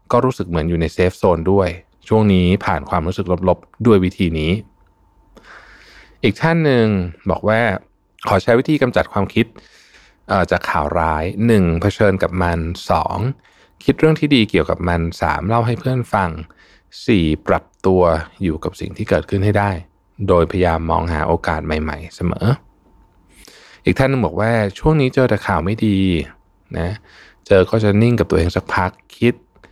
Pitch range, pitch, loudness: 85-110 Hz, 95 Hz, -17 LUFS